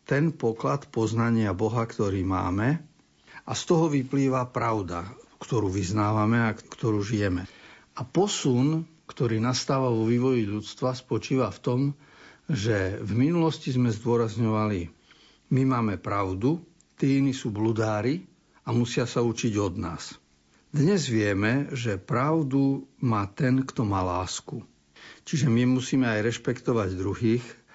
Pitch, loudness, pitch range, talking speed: 120 Hz, -26 LUFS, 105-135 Hz, 130 wpm